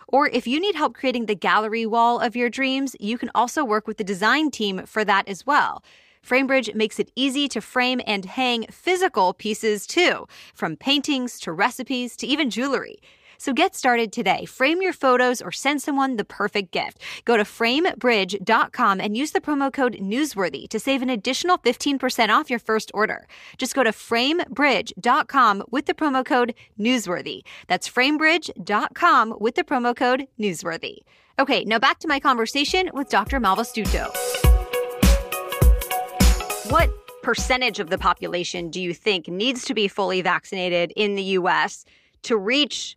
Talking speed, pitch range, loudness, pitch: 160 wpm, 210-275 Hz, -22 LUFS, 245 Hz